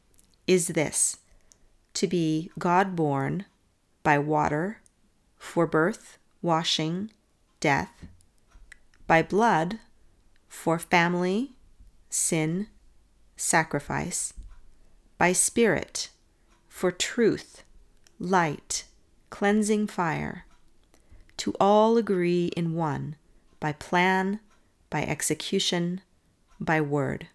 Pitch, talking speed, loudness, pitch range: 170 Hz, 80 wpm, -26 LUFS, 150-195 Hz